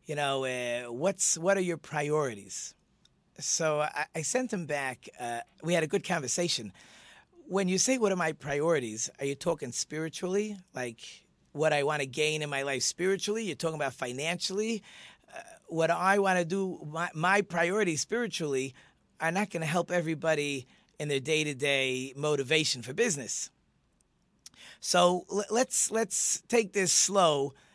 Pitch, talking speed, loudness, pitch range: 160 Hz, 160 wpm, -30 LUFS, 140-190 Hz